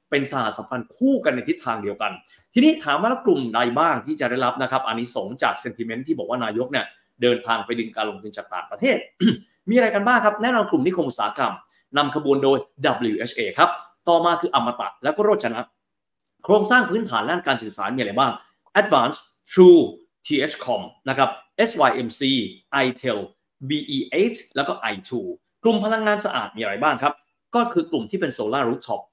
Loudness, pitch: -21 LUFS, 155 Hz